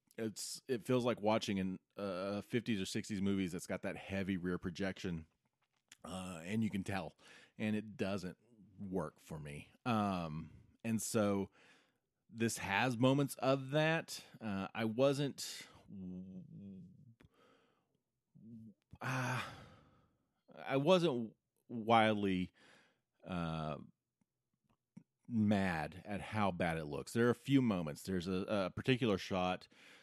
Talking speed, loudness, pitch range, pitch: 120 wpm, -38 LUFS, 95-120 Hz, 100 Hz